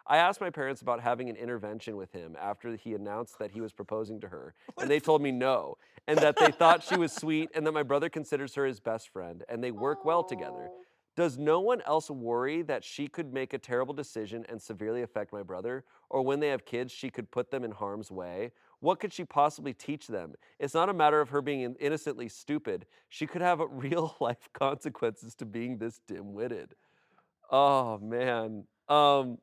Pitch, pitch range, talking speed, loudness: 130 Hz, 115-155 Hz, 210 wpm, -31 LUFS